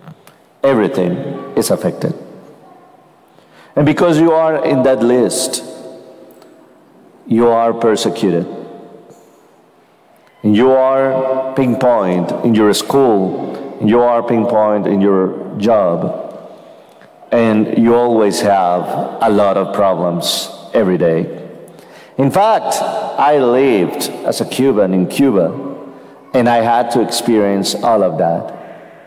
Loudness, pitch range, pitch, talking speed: -14 LUFS, 105-130 Hz, 120 Hz, 105 wpm